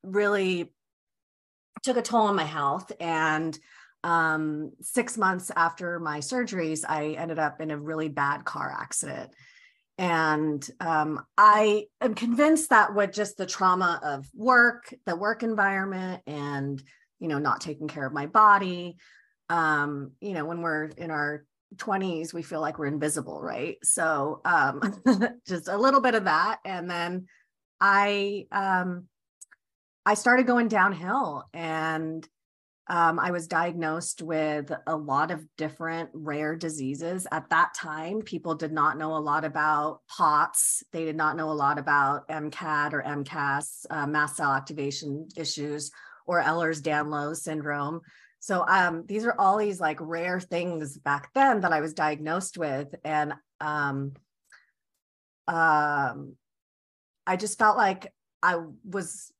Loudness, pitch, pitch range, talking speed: -26 LUFS, 165 Hz, 150-195 Hz, 145 wpm